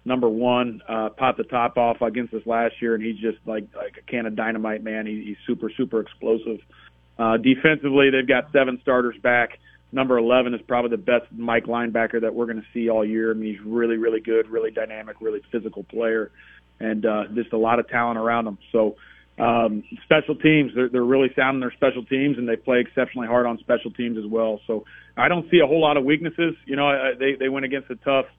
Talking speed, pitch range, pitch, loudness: 220 wpm, 115-130 Hz, 120 Hz, -22 LUFS